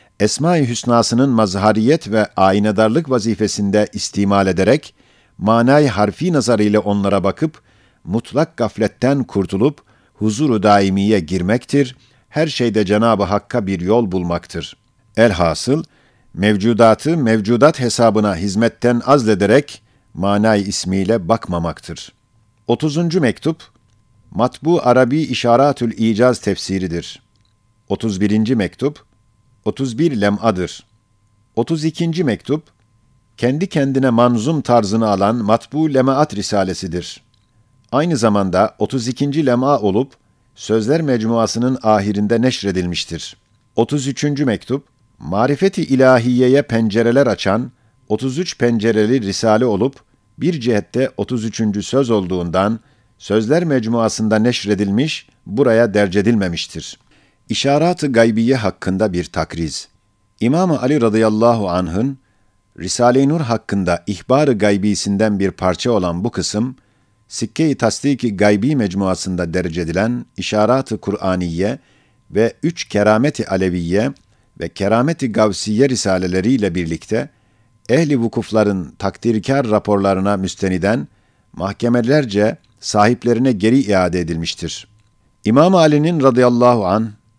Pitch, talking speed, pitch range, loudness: 115 Hz, 95 wpm, 100-130 Hz, -16 LUFS